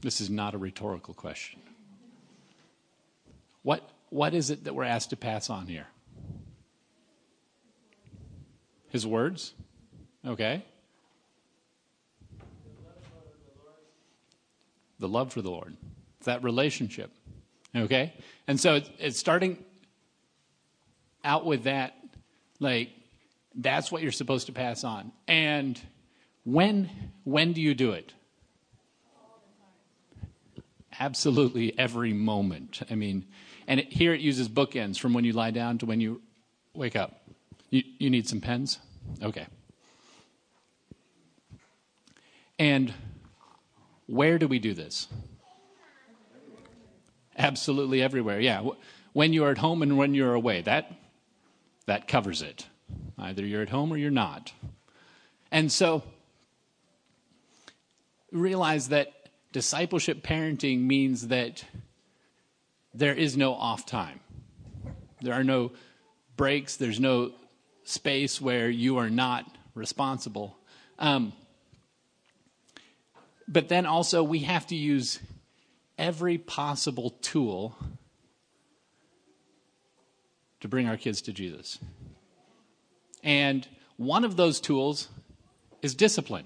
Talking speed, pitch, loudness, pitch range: 110 wpm, 130 Hz, -28 LUFS, 115-155 Hz